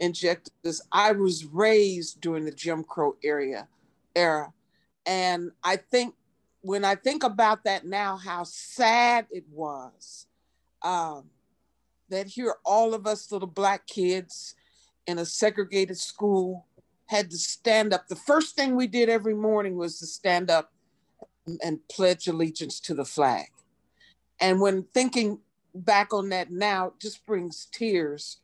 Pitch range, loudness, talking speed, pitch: 170-215 Hz, -26 LUFS, 145 wpm, 185 Hz